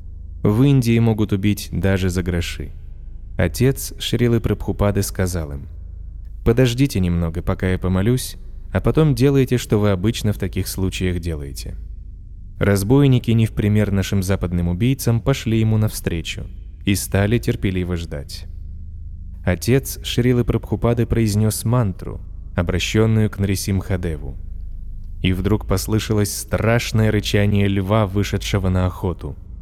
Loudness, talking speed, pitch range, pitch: -19 LUFS, 120 wpm, 85-110 Hz, 95 Hz